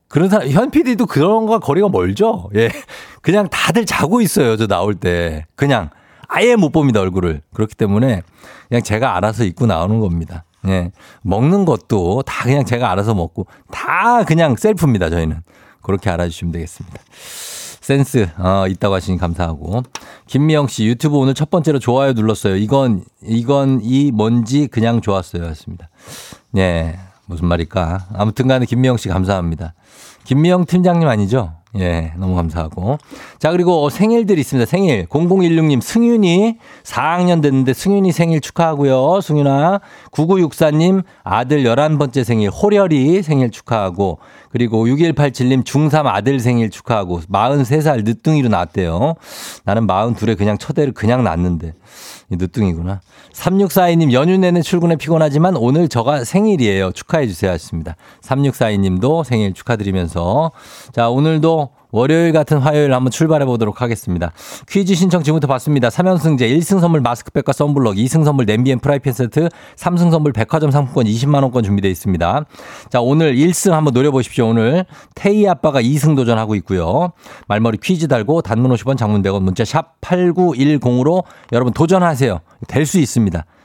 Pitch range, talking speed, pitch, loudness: 105-160 Hz, 335 characters per minute, 130 Hz, -15 LUFS